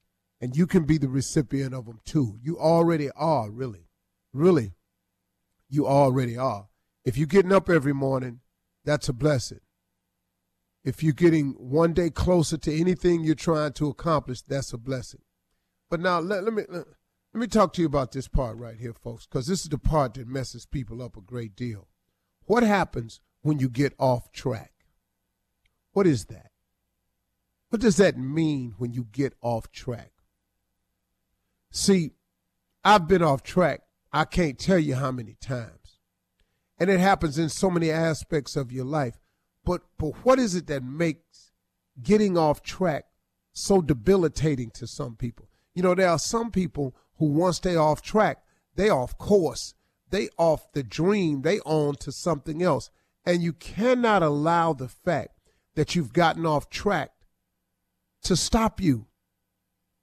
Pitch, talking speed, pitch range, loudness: 140 Hz, 165 wpm, 105-165 Hz, -25 LUFS